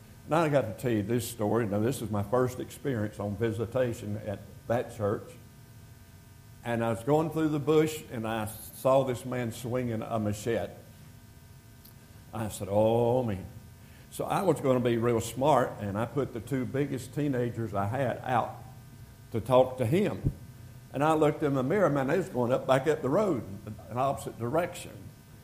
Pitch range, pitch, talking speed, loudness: 110-130 Hz, 120 Hz, 185 wpm, -29 LUFS